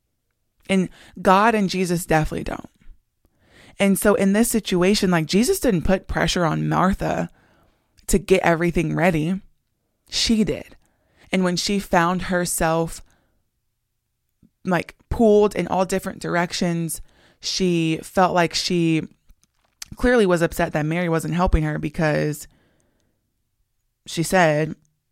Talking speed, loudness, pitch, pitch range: 120 wpm, -21 LUFS, 175 Hz, 155-190 Hz